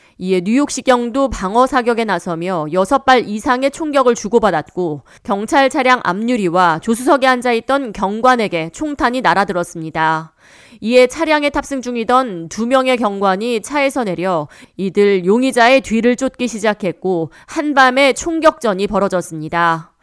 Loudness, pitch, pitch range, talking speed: -15 LUFS, 230 Hz, 185-260 Hz, 310 characters per minute